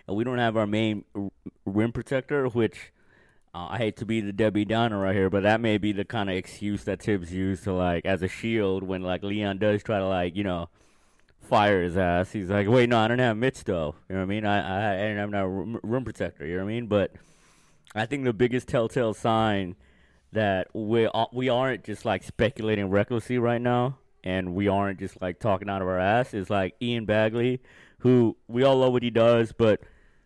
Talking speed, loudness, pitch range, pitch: 220 wpm, -26 LUFS, 95-115 Hz, 105 Hz